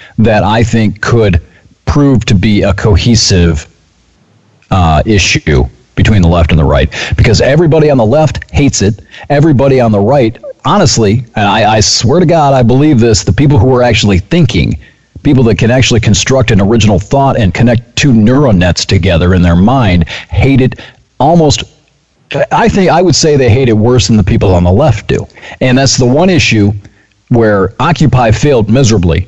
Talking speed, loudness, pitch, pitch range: 180 wpm, -8 LUFS, 110 Hz, 100-130 Hz